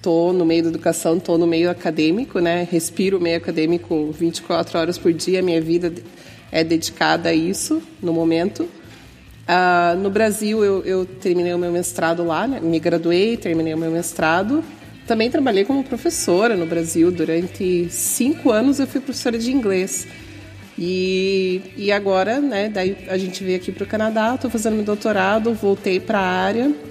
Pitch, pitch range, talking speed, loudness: 180 Hz, 170-210 Hz, 170 wpm, -19 LUFS